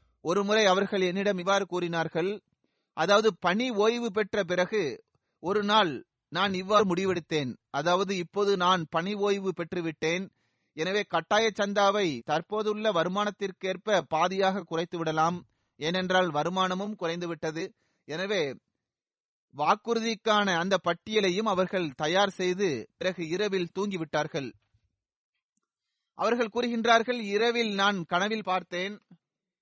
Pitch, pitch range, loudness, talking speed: 190 Hz, 170-210 Hz, -28 LUFS, 95 wpm